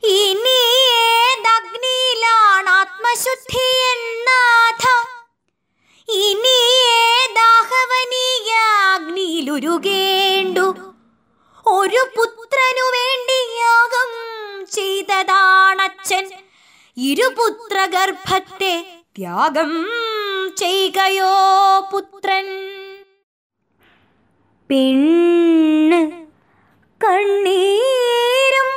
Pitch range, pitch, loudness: 375-470 Hz, 395 Hz, -15 LUFS